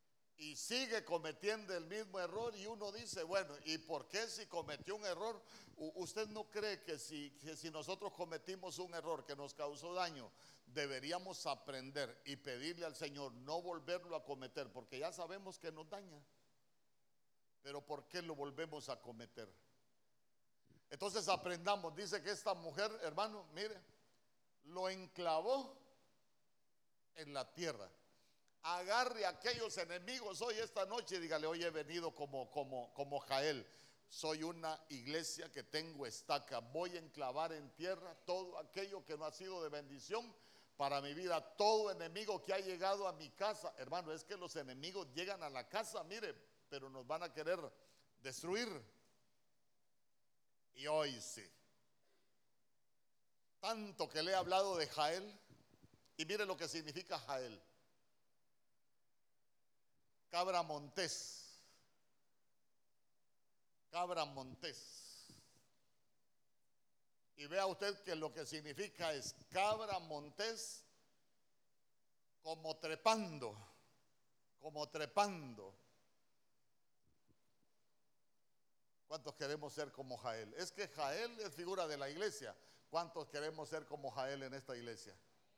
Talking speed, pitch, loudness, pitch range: 130 wpm, 165 Hz, -45 LUFS, 145-195 Hz